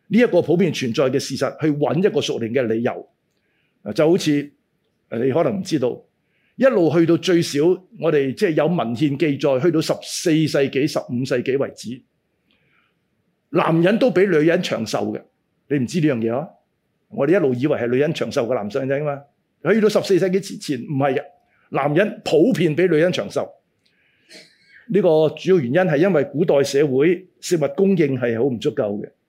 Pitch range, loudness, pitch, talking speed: 140-185 Hz, -19 LUFS, 155 Hz, 270 characters per minute